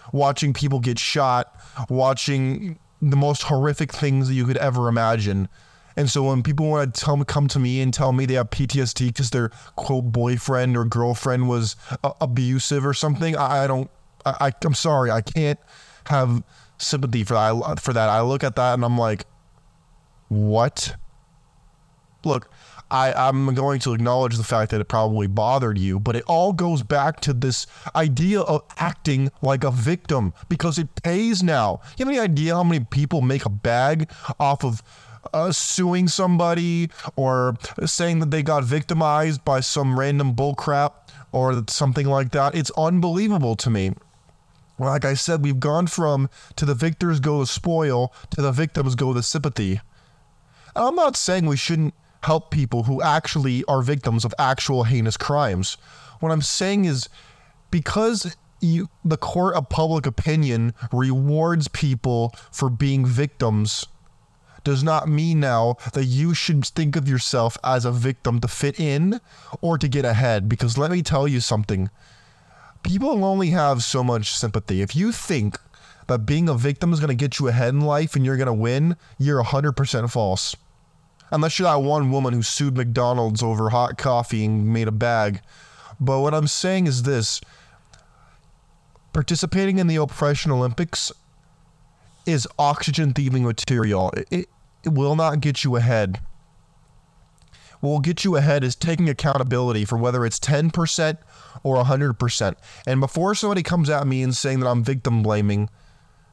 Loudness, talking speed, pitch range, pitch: -21 LUFS, 170 wpm, 120-155 Hz, 140 Hz